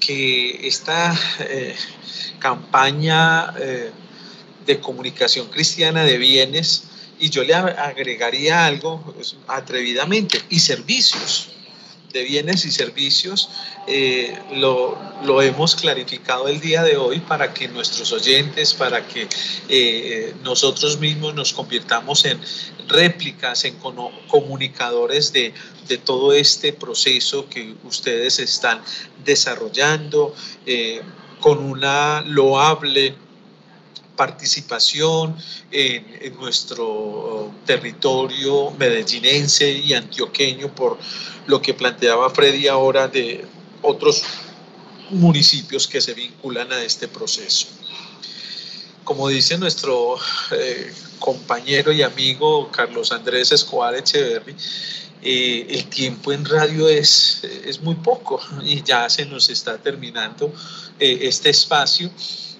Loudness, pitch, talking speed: -17 LUFS, 165 Hz, 105 wpm